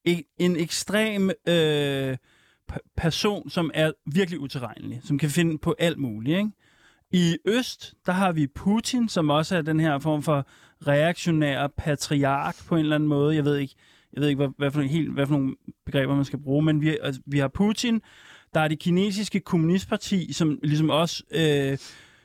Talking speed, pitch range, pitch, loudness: 185 wpm, 145-175 Hz, 155 Hz, -25 LUFS